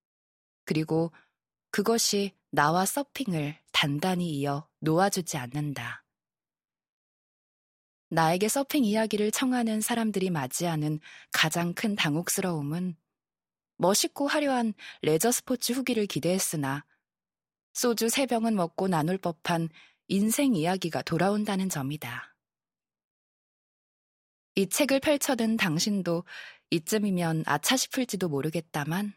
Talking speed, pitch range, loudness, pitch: 245 characters per minute, 155-225 Hz, -28 LUFS, 185 Hz